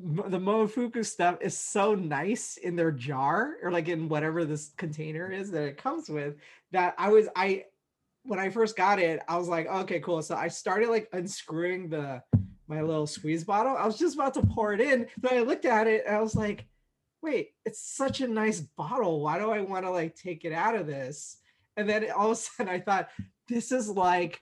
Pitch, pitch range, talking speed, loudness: 185 Hz, 160-215 Hz, 220 wpm, -29 LUFS